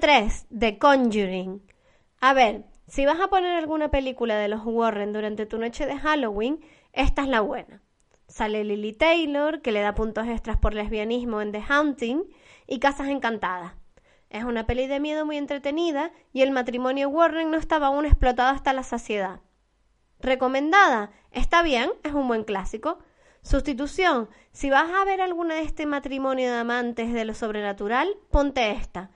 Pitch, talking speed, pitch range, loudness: 260 Hz, 165 wpm, 220-300 Hz, -24 LUFS